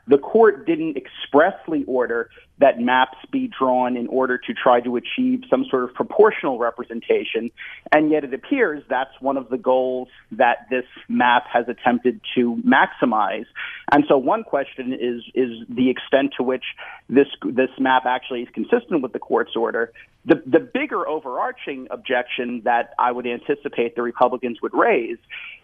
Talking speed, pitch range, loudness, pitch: 160 wpm, 125-145 Hz, -21 LUFS, 130 Hz